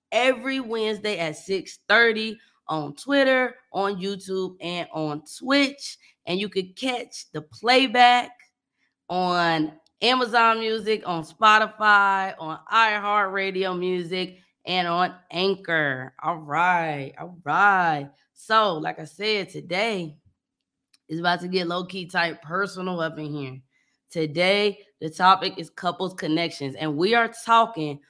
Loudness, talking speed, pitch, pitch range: -23 LUFS, 120 wpm, 185 Hz, 165-220 Hz